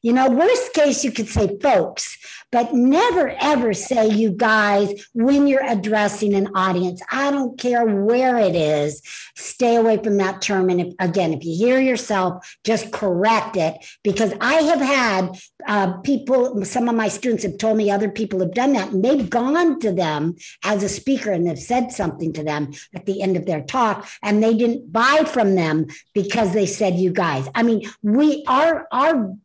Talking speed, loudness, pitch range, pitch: 195 wpm, -19 LUFS, 190-245 Hz, 215 Hz